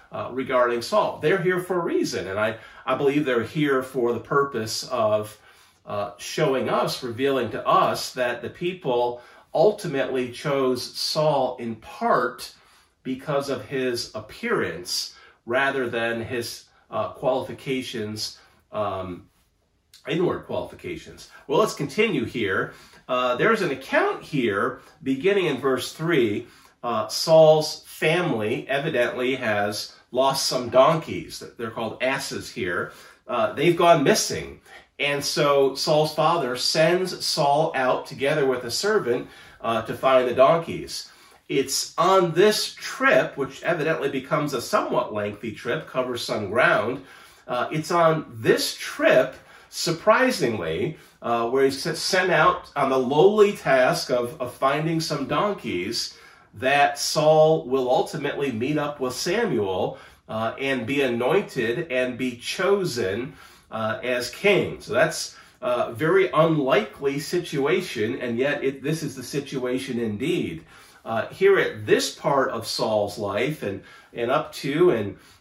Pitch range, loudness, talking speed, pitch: 120-160 Hz, -23 LUFS, 135 wpm, 135 Hz